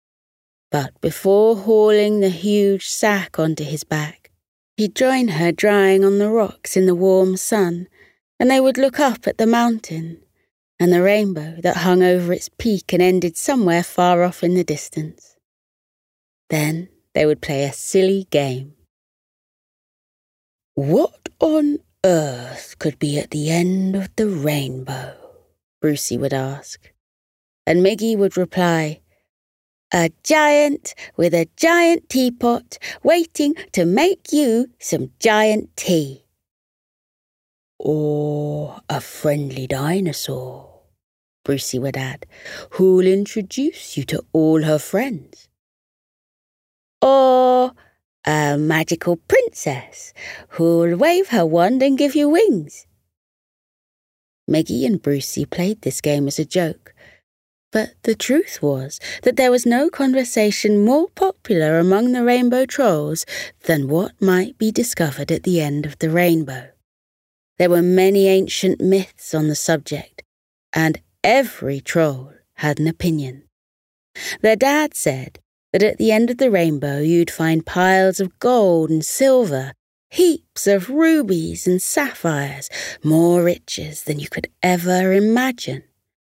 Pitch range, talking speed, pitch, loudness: 150-220 Hz, 130 wpm, 180 Hz, -18 LUFS